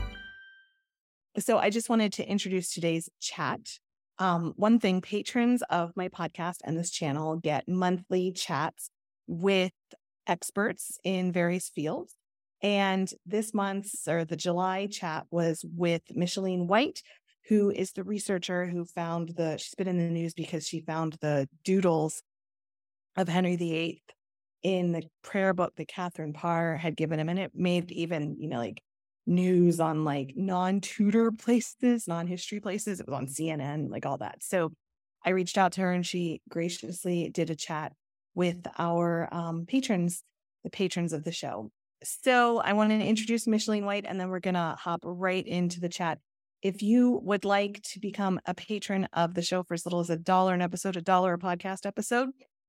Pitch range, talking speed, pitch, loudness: 165-200 Hz, 170 wpm, 180 Hz, -30 LUFS